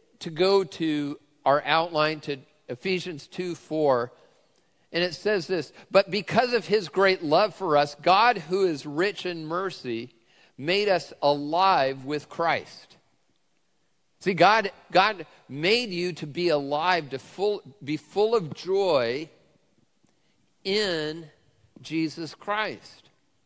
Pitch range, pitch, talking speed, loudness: 150-195 Hz, 170 Hz, 125 wpm, -25 LUFS